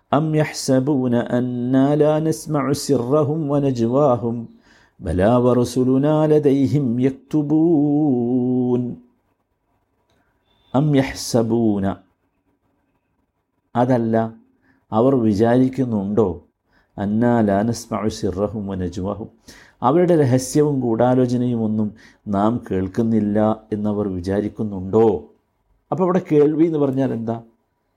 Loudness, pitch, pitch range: -19 LUFS, 120 Hz, 110-140 Hz